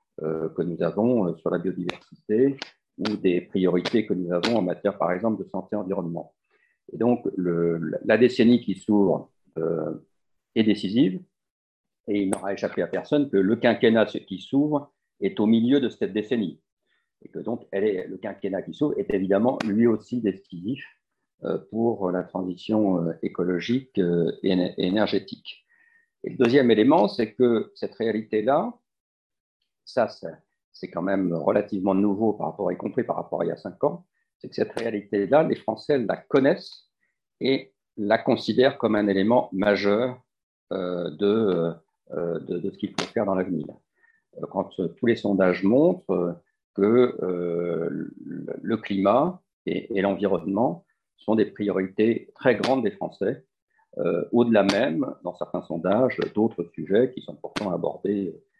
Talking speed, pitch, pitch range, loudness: 155 wpm, 100 Hz, 90-120 Hz, -24 LUFS